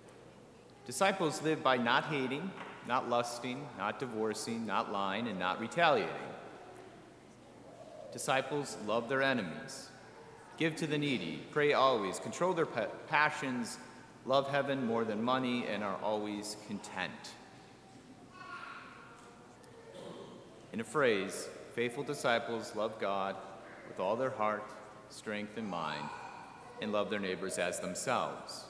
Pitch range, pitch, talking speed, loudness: 105-140 Hz, 120 Hz, 115 wpm, -35 LUFS